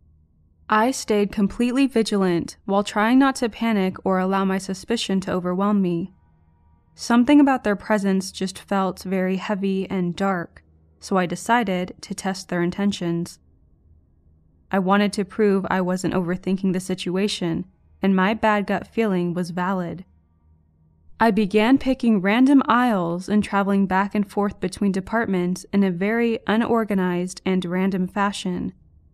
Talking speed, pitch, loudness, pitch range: 140 wpm, 190 Hz, -22 LUFS, 180-210 Hz